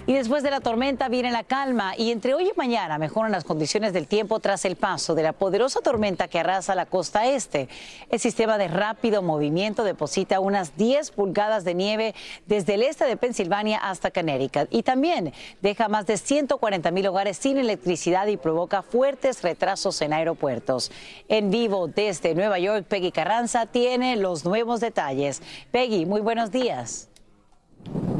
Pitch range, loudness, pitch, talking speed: 175-235 Hz, -24 LUFS, 205 Hz, 170 wpm